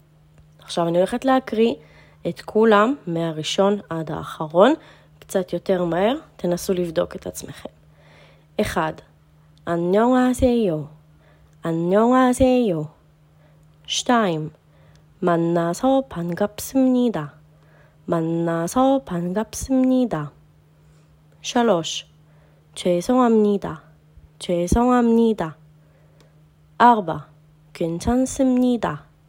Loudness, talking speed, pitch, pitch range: -21 LUFS, 65 wpm, 170 Hz, 150-225 Hz